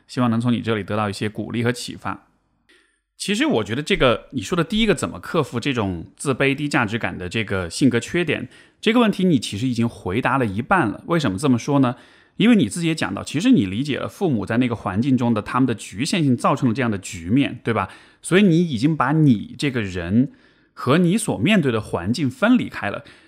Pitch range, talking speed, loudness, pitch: 115-155 Hz, 340 characters per minute, -20 LUFS, 125 Hz